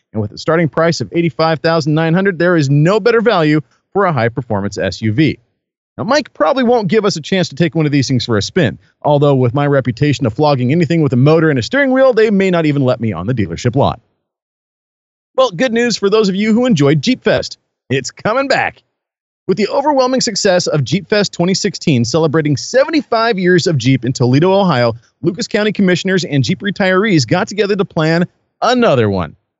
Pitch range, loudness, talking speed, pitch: 140-205 Hz, -13 LUFS, 205 wpm, 170 Hz